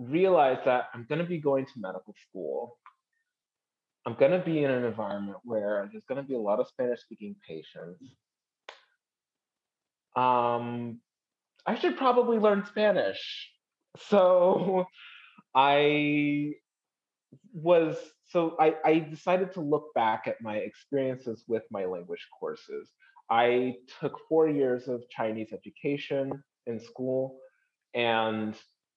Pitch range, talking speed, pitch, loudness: 120-180 Hz, 125 wpm, 145 Hz, -28 LUFS